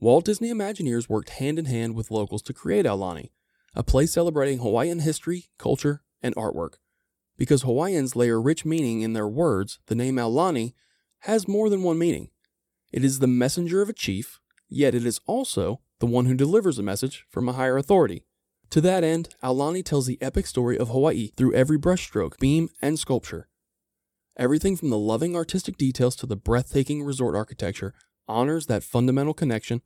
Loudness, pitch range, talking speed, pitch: -24 LUFS, 120-160 Hz, 175 wpm, 130 Hz